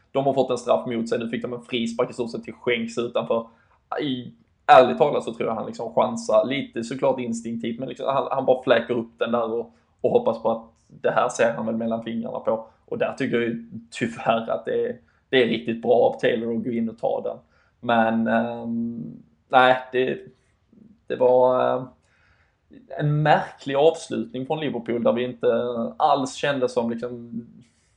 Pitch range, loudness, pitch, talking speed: 115-125 Hz, -23 LUFS, 120 Hz, 195 wpm